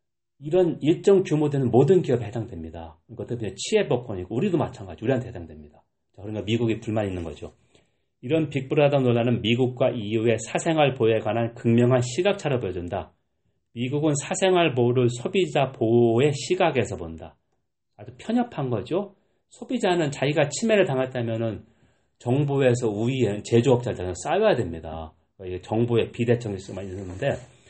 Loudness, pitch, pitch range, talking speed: -24 LUFS, 120 Hz, 110-145 Hz, 360 characters per minute